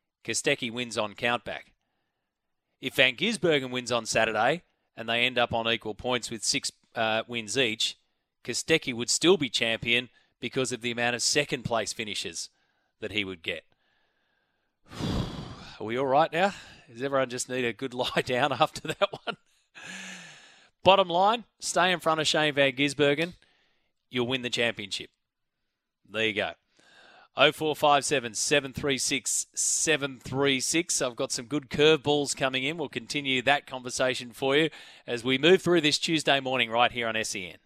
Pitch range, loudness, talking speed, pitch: 120-150 Hz, -26 LUFS, 155 wpm, 130 Hz